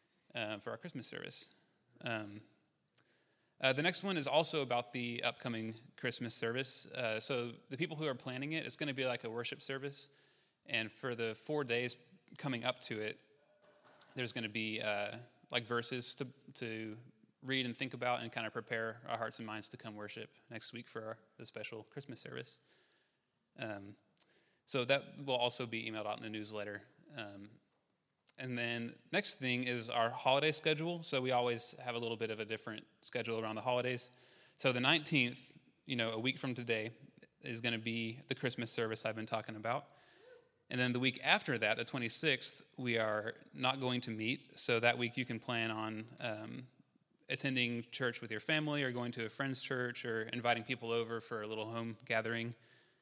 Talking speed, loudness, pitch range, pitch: 190 wpm, -38 LUFS, 115-130 Hz, 120 Hz